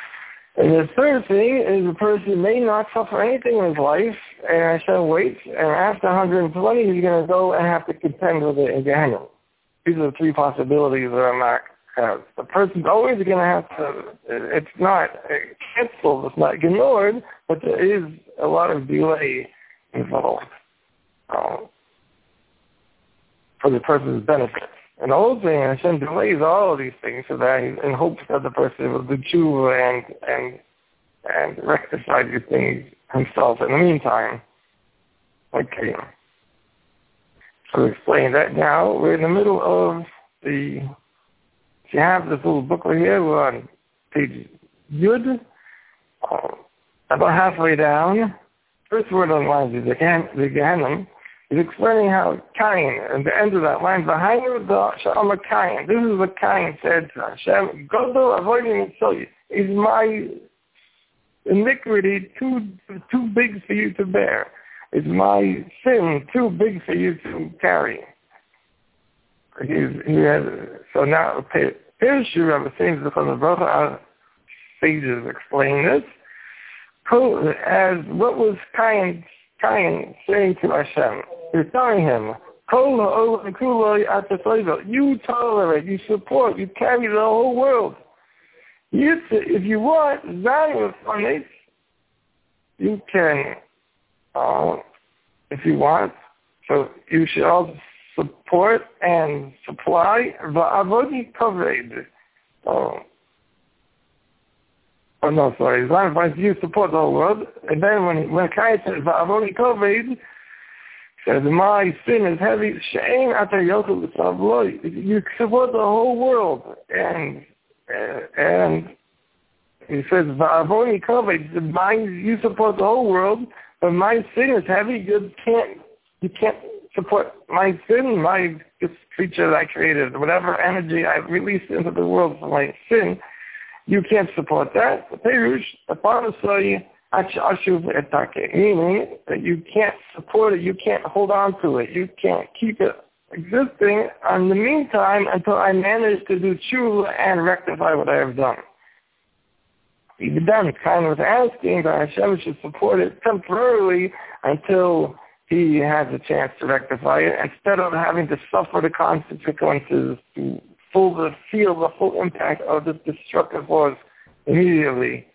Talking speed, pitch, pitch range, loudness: 140 wpm, 195 Hz, 160-225 Hz, -20 LUFS